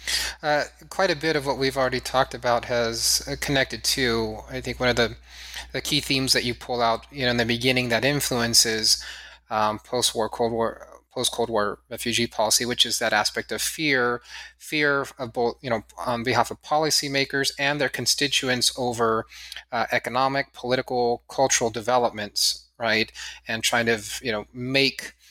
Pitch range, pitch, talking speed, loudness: 115-135 Hz, 125 Hz, 175 wpm, -23 LUFS